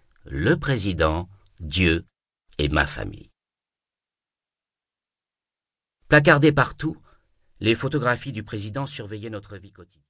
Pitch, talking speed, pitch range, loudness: 110 Hz, 95 wpm, 90-135 Hz, -22 LUFS